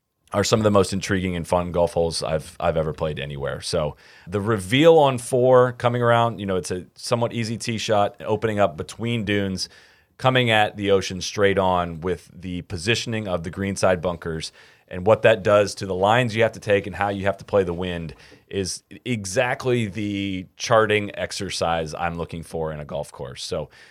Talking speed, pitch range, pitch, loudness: 200 wpm, 90-115 Hz, 100 Hz, -22 LUFS